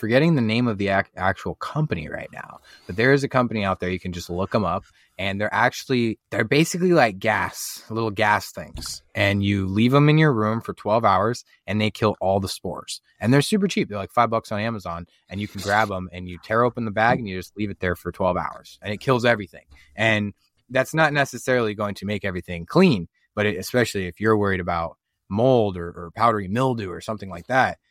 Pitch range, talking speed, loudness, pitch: 95-115 Hz, 230 wpm, -22 LUFS, 105 Hz